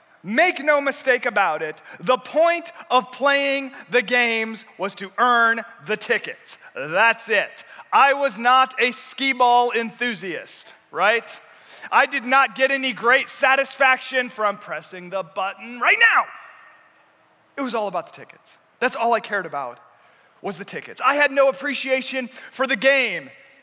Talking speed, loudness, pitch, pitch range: 150 wpm, -20 LUFS, 250 Hz, 225-270 Hz